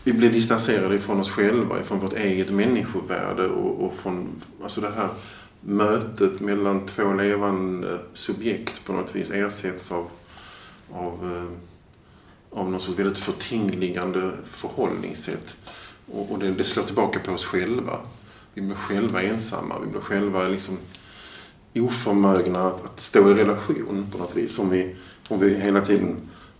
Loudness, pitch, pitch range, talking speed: -24 LUFS, 100 Hz, 90-100 Hz, 140 wpm